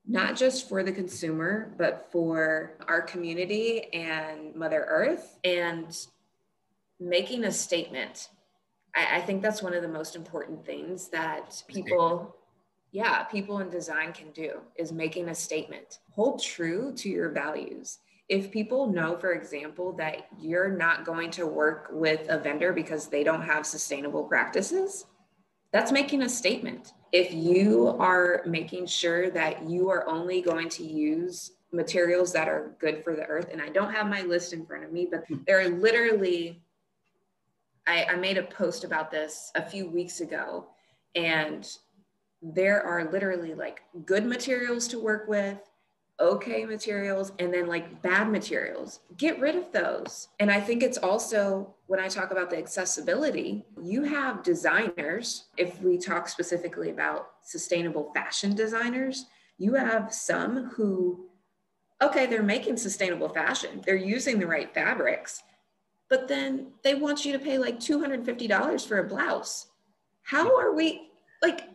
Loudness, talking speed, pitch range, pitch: -28 LUFS, 155 wpm, 170-225 Hz, 185 Hz